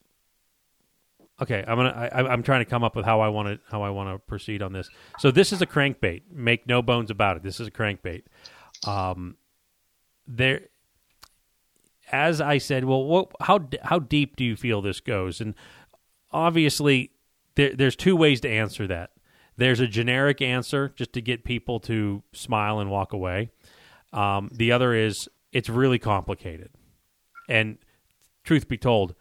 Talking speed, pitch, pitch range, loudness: 170 wpm, 120 Hz, 105-135 Hz, -24 LUFS